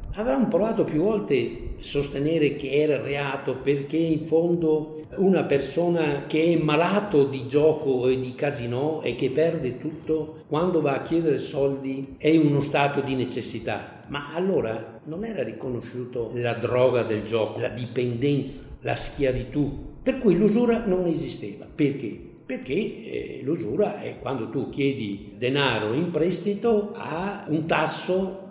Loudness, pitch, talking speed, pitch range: -25 LUFS, 145 Hz, 145 wpm, 130-165 Hz